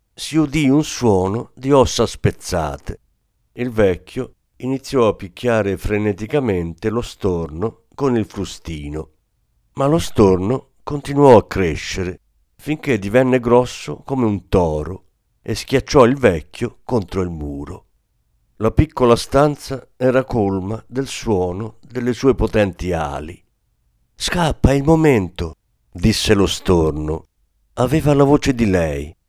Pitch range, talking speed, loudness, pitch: 95-130 Hz, 120 wpm, -18 LUFS, 110 Hz